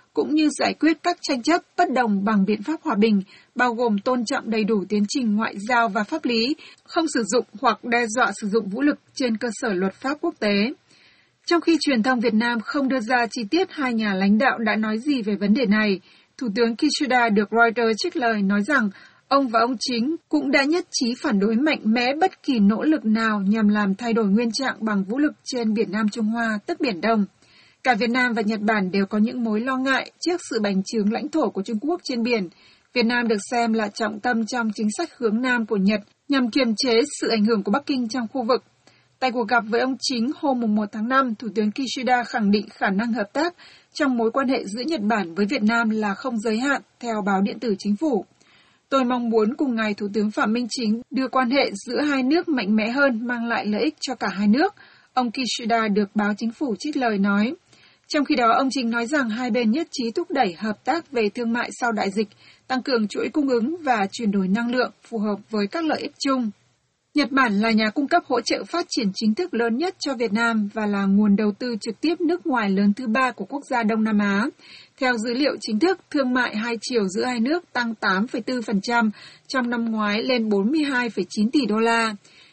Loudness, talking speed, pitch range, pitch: -22 LUFS, 240 wpm, 215-270 Hz, 235 Hz